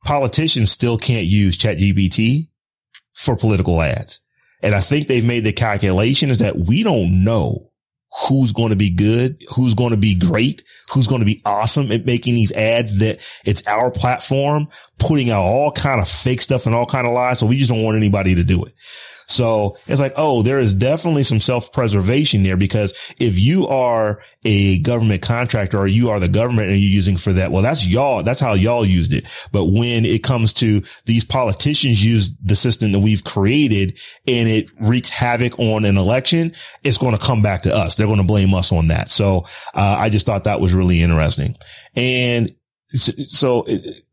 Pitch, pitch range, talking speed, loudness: 115 Hz, 100-125 Hz, 200 wpm, -16 LUFS